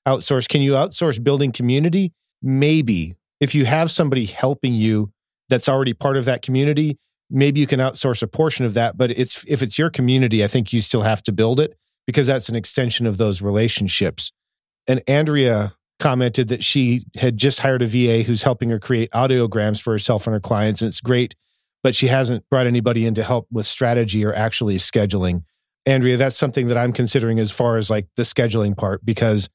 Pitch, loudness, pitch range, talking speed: 125 Hz, -19 LUFS, 110-135 Hz, 200 wpm